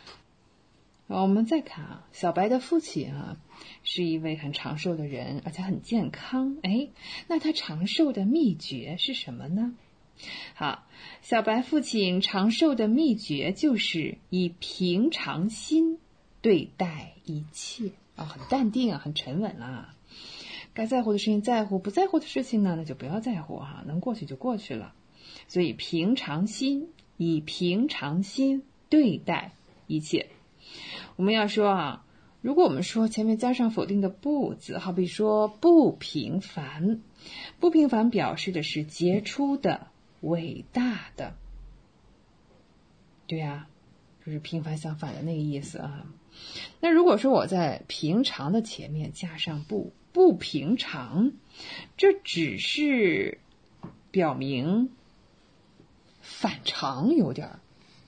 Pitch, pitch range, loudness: 195 Hz, 165-245 Hz, -27 LUFS